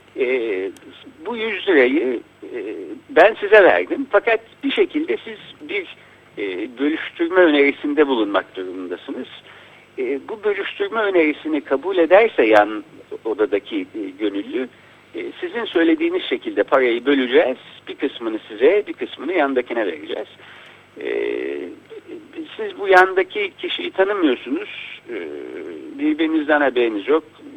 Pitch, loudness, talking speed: 345 Hz, -19 LUFS, 110 wpm